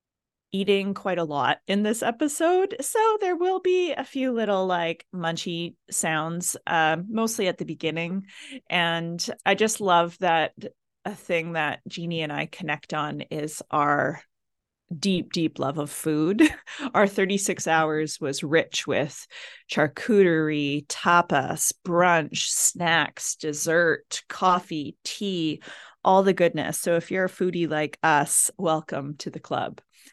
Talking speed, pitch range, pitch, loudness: 135 wpm, 155-200 Hz, 175 Hz, -24 LUFS